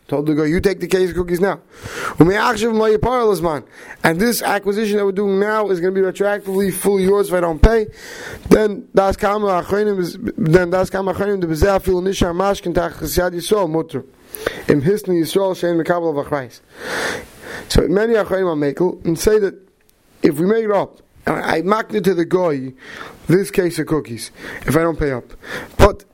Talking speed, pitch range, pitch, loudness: 125 wpm, 170-205 Hz, 190 Hz, -17 LUFS